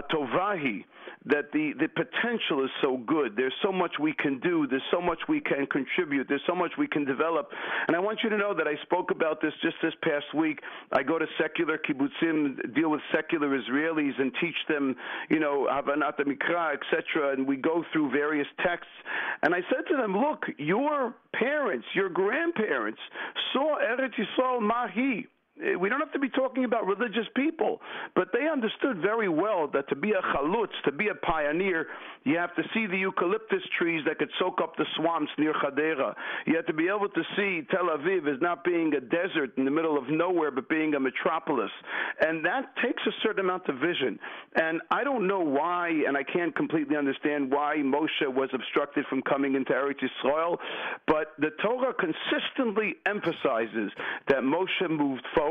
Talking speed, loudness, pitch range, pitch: 190 wpm, -28 LUFS, 145-225 Hz, 165 Hz